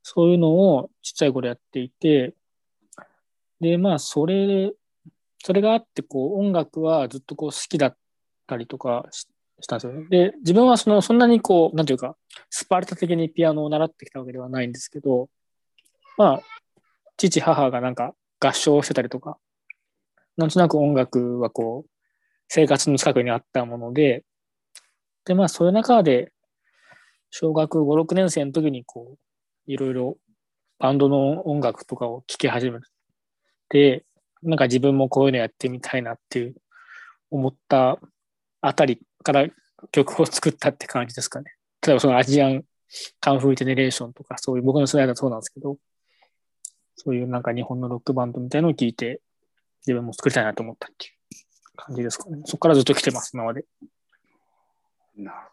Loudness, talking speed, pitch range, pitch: -21 LUFS, 345 characters per minute, 125-165 Hz, 140 Hz